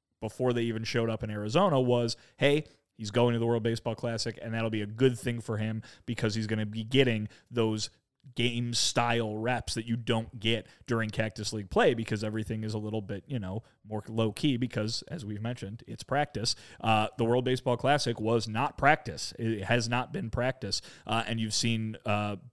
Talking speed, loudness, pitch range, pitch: 205 wpm, -30 LUFS, 110-120 Hz, 115 Hz